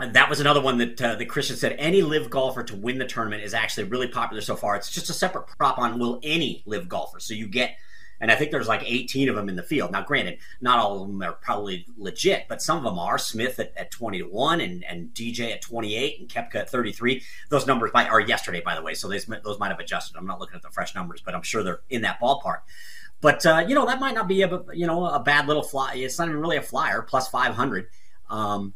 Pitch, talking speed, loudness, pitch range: 130 Hz, 260 wpm, -24 LUFS, 115-160 Hz